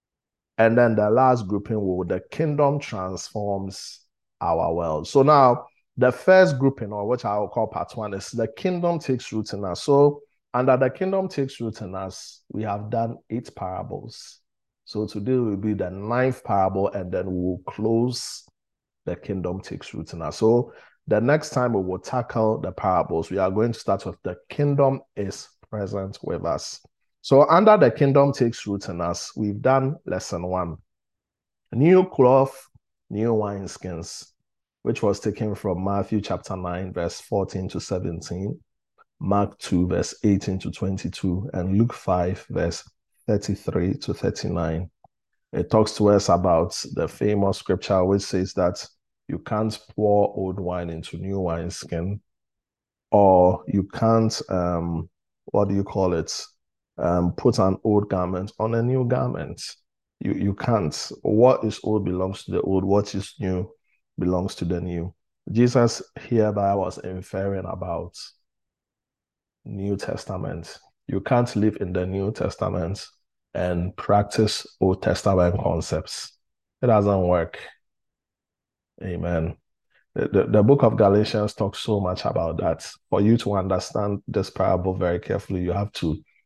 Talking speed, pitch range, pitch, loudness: 155 wpm, 95-115 Hz, 100 Hz, -23 LUFS